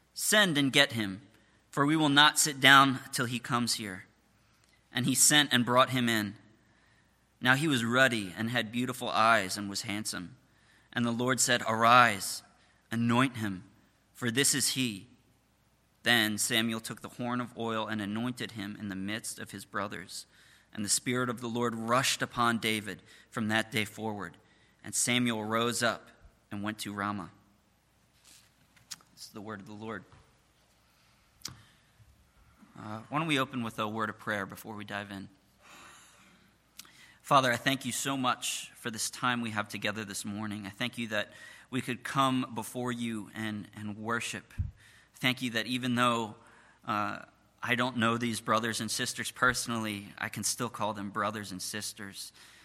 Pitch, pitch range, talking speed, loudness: 115 Hz, 105-125 Hz, 170 wpm, -29 LUFS